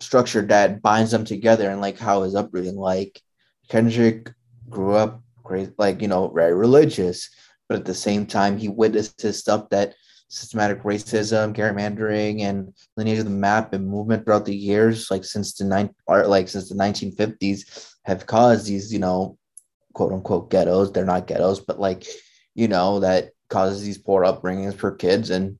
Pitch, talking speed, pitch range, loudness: 100 Hz, 180 wpm, 95-110 Hz, -21 LUFS